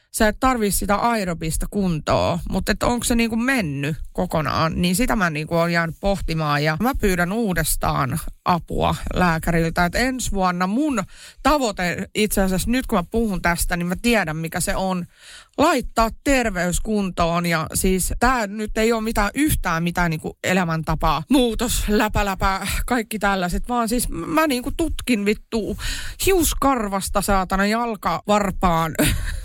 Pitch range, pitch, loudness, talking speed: 175-230 Hz, 200 Hz, -21 LUFS, 145 wpm